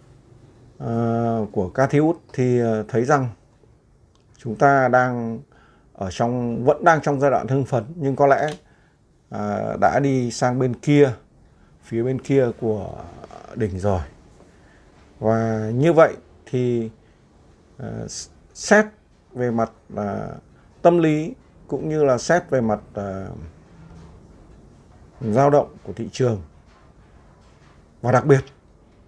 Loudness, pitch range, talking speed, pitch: -21 LUFS, 105-135 Hz, 125 wpm, 120 Hz